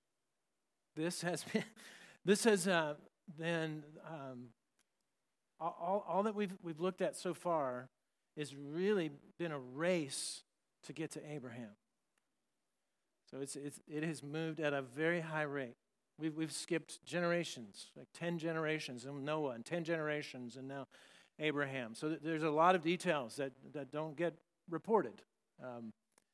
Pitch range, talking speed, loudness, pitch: 140-170 Hz, 145 wpm, -39 LUFS, 160 Hz